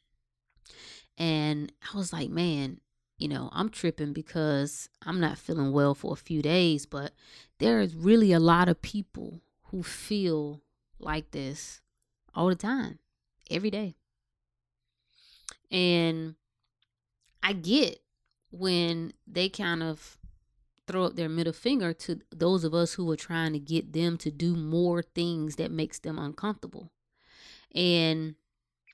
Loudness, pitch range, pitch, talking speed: -29 LUFS, 145-175 Hz, 165 Hz, 135 wpm